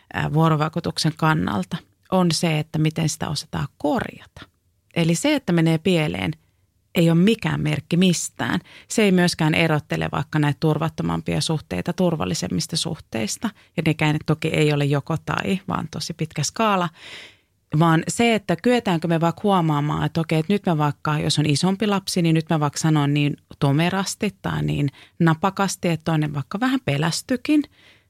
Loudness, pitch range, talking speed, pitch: -22 LUFS, 150-175 Hz, 155 wpm, 160 Hz